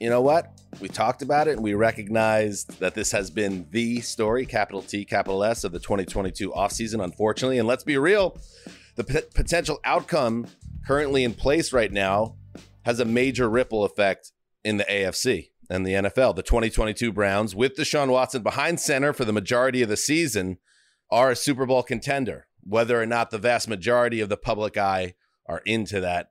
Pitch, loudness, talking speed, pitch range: 115 Hz, -24 LUFS, 185 wpm, 100-130 Hz